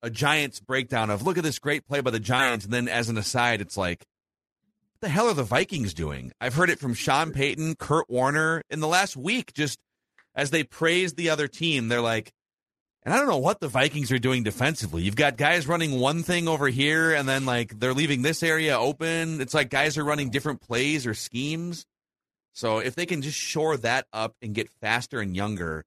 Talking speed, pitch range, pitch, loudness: 220 wpm, 120-155 Hz, 135 Hz, -25 LUFS